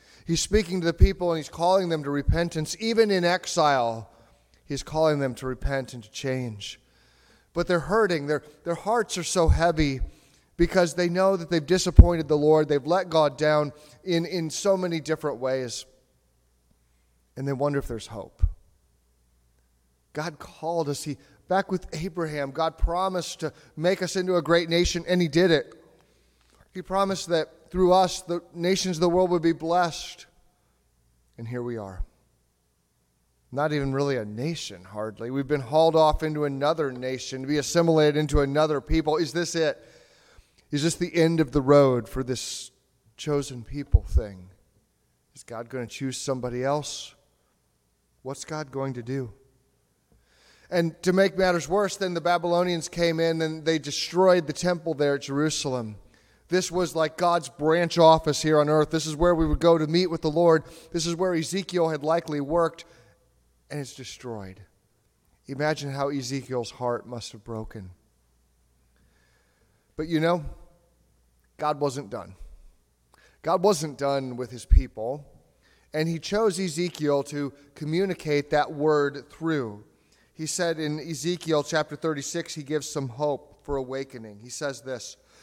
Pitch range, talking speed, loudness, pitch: 120-170 Hz, 160 wpm, -25 LUFS, 150 Hz